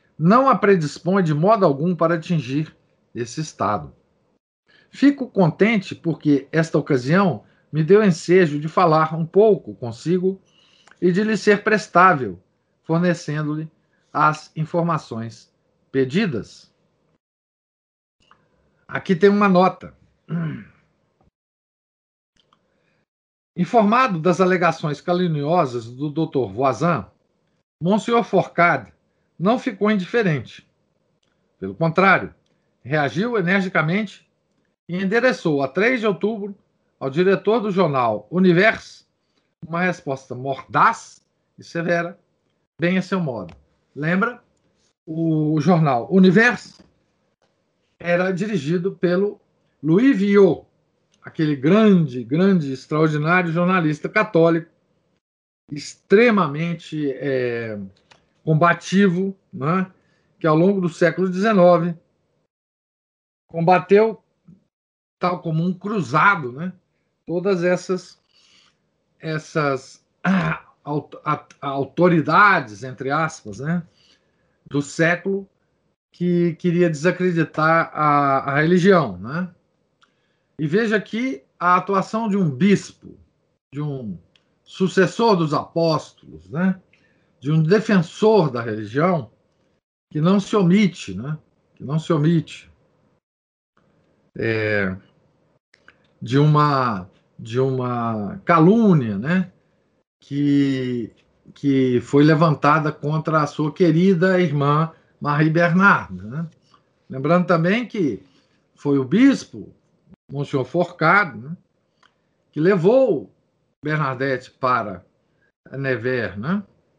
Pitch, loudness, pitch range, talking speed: 170 Hz, -19 LUFS, 145-185 Hz, 95 wpm